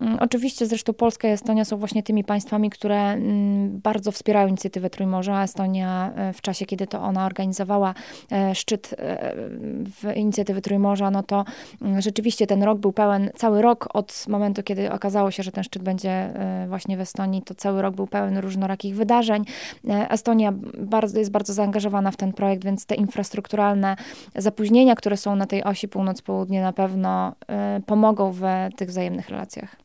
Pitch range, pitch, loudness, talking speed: 195-215 Hz, 200 Hz, -23 LUFS, 155 wpm